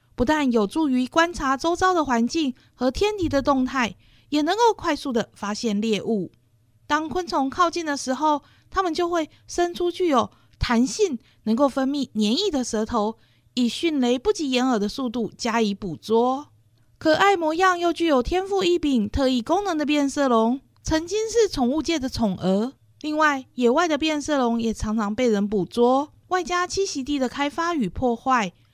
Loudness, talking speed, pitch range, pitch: -23 LUFS, 255 characters per minute, 230-330 Hz, 270 Hz